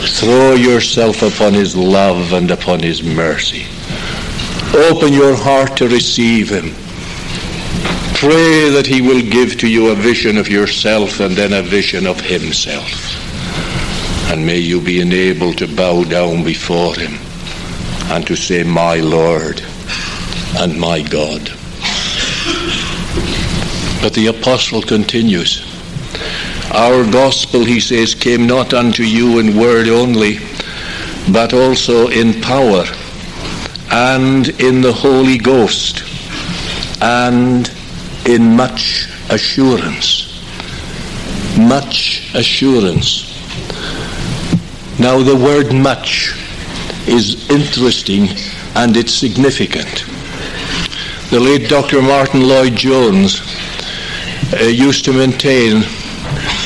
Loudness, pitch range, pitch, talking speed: -12 LUFS, 95-130 Hz, 115 Hz, 105 wpm